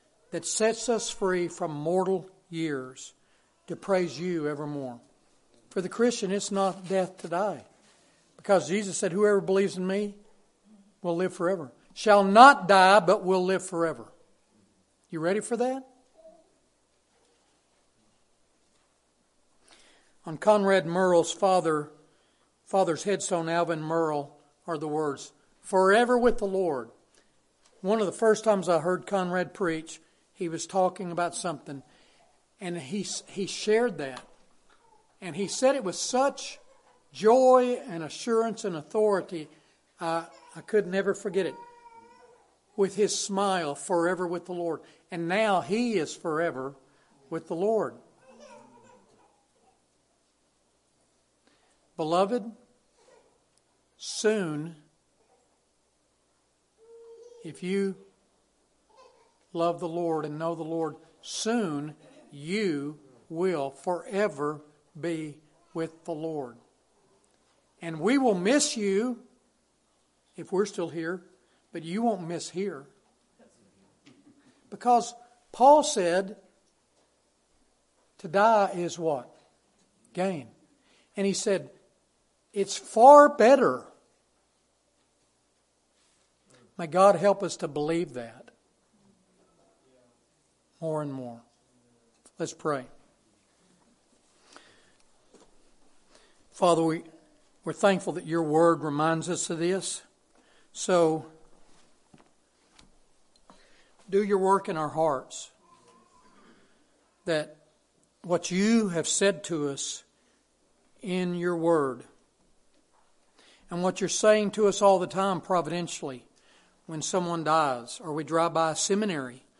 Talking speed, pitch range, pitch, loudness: 105 wpm, 165-205 Hz, 185 Hz, -26 LUFS